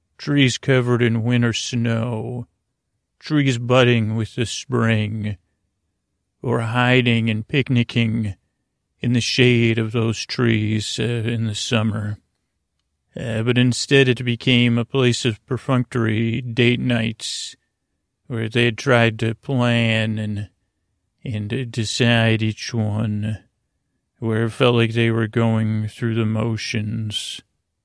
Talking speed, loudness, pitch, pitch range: 120 wpm, -20 LUFS, 115 Hz, 110-120 Hz